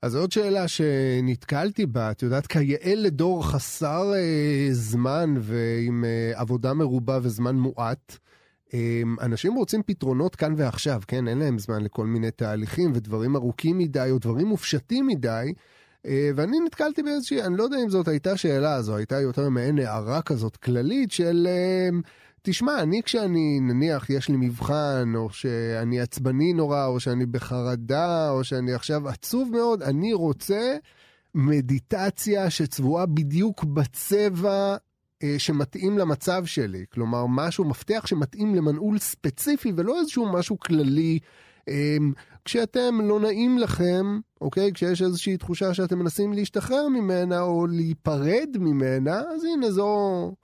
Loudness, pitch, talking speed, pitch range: -25 LUFS, 155 Hz, 140 wpm, 130-195 Hz